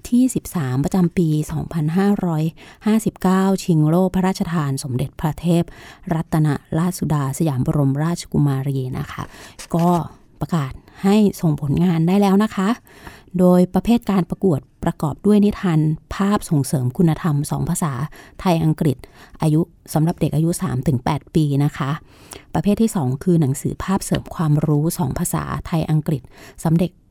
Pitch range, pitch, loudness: 150-185 Hz, 165 Hz, -20 LUFS